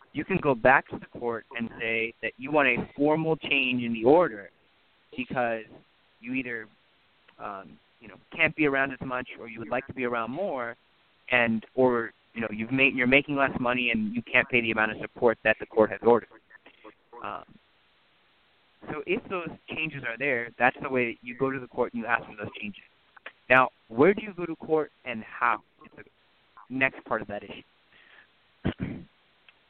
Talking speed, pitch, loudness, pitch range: 200 wpm, 125 Hz, -26 LUFS, 115-140 Hz